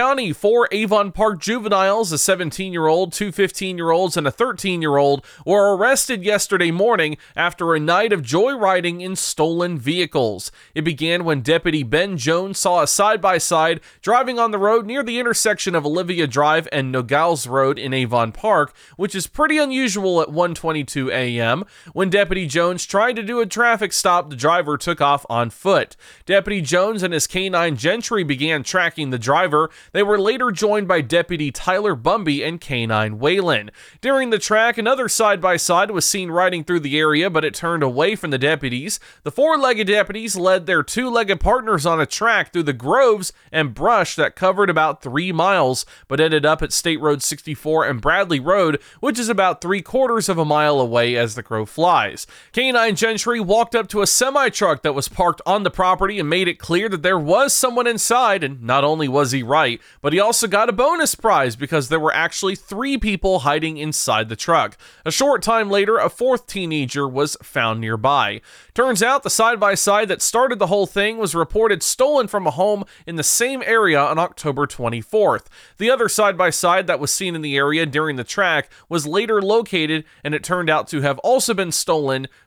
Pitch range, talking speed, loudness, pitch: 150-210 Hz, 190 wpm, -18 LUFS, 180 Hz